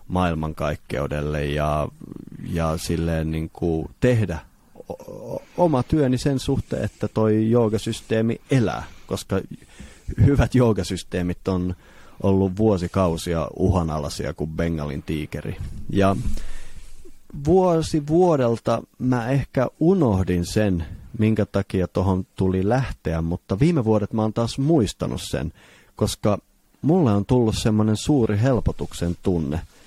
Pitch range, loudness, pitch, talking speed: 85-120 Hz, -22 LUFS, 100 Hz, 105 wpm